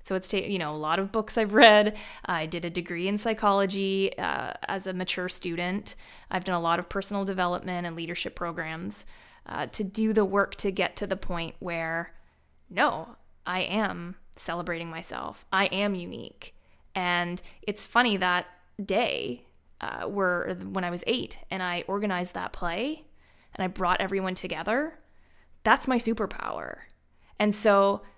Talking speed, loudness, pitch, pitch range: 165 wpm, -28 LUFS, 185 Hz, 175-205 Hz